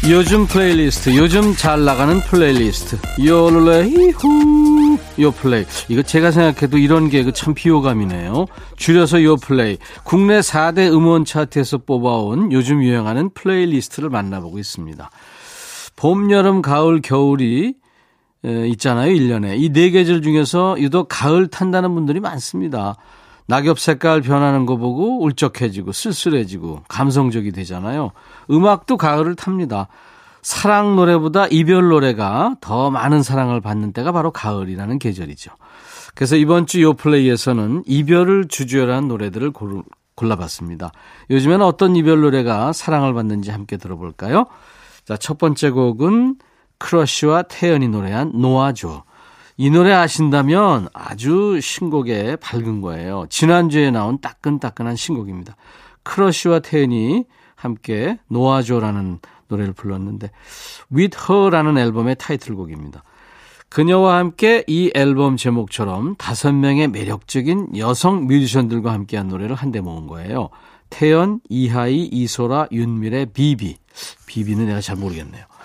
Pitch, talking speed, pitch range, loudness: 140 Hz, 325 characters per minute, 115-170 Hz, -16 LUFS